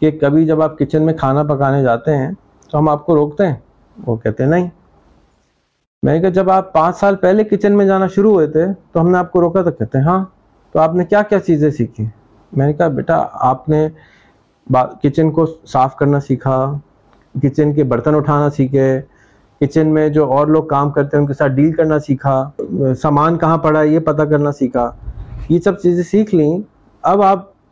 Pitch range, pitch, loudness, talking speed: 135-170 Hz, 150 Hz, -14 LUFS, 205 wpm